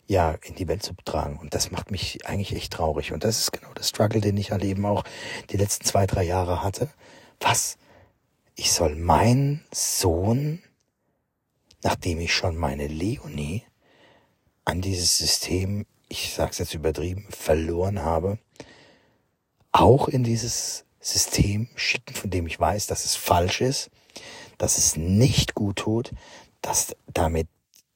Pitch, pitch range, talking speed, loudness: 95 Hz, 85-110 Hz, 150 wpm, -24 LUFS